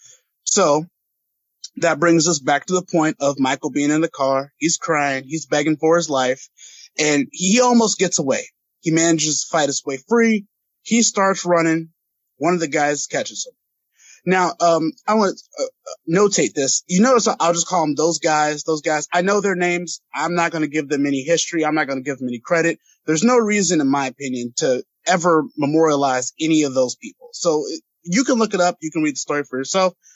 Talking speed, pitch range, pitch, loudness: 210 wpm, 145-185 Hz, 165 Hz, -19 LUFS